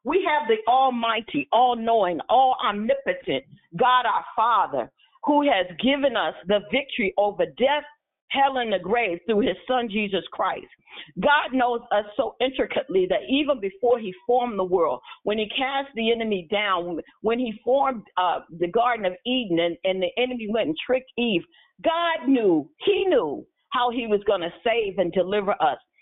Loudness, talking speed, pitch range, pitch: -23 LUFS, 175 wpm, 205-270 Hz, 235 Hz